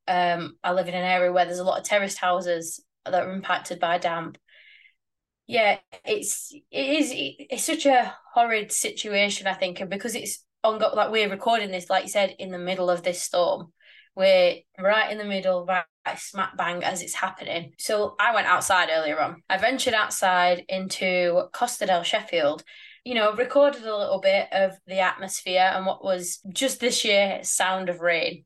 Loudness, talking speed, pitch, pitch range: -24 LUFS, 185 wpm, 190 Hz, 180-235 Hz